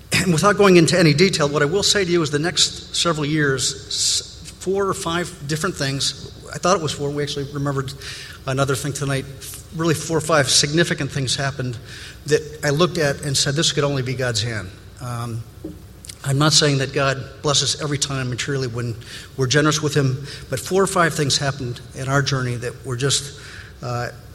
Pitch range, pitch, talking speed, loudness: 130-155 Hz, 140 Hz, 195 wpm, -19 LUFS